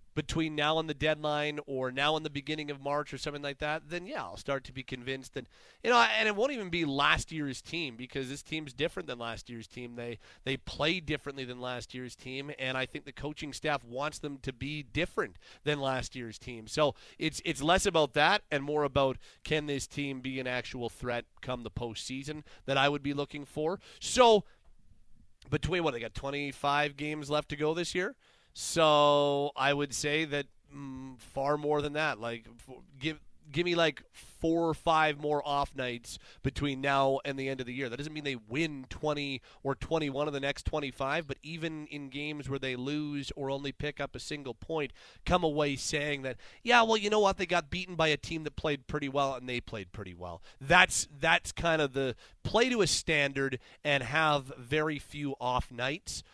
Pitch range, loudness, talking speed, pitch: 130-155 Hz, -31 LUFS, 210 wpm, 145 Hz